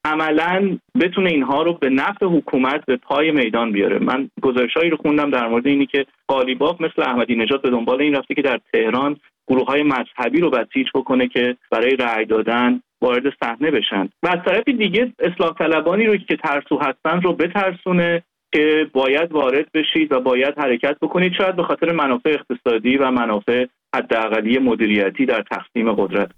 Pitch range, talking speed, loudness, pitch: 125-165 Hz, 170 wpm, -18 LUFS, 145 Hz